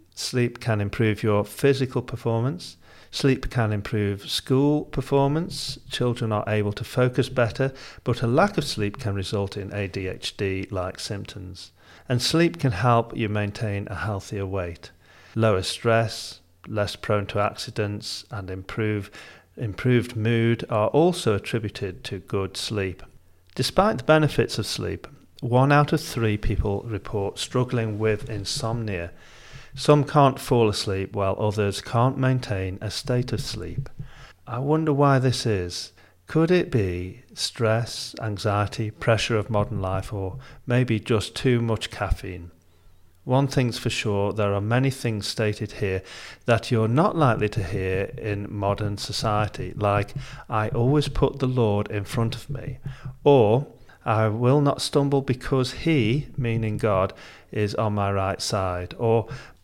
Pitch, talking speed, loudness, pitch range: 110 Hz, 145 wpm, -24 LUFS, 100-130 Hz